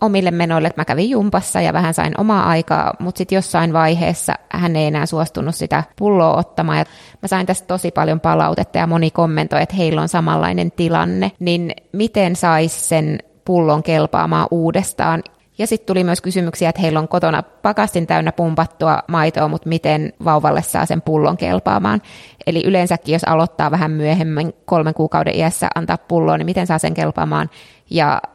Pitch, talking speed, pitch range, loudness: 165 Hz, 170 wpm, 155-180 Hz, -17 LUFS